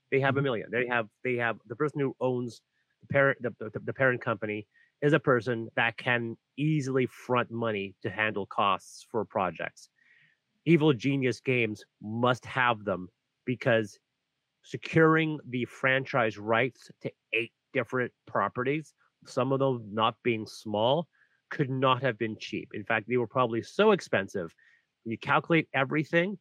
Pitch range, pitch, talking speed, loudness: 115-135 Hz, 125 Hz, 155 wpm, -29 LUFS